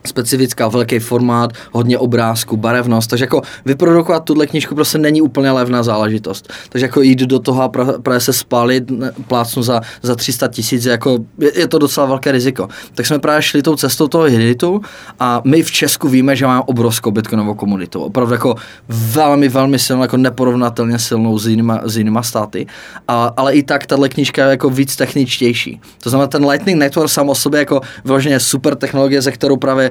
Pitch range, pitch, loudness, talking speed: 120-140 Hz, 130 Hz, -13 LUFS, 185 wpm